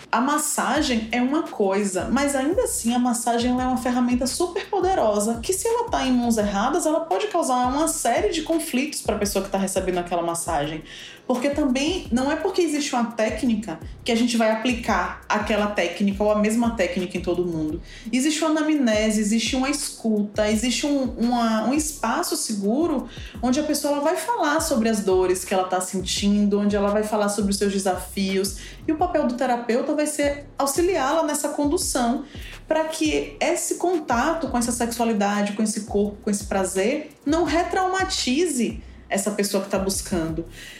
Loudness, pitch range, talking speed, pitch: -23 LUFS, 205-300 Hz, 180 wpm, 245 Hz